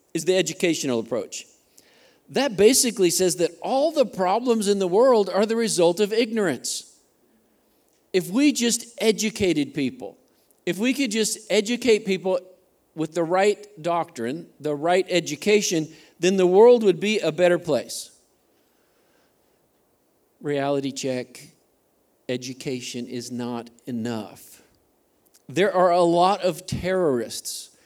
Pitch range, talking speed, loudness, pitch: 150-210 Hz, 125 wpm, -22 LUFS, 180 Hz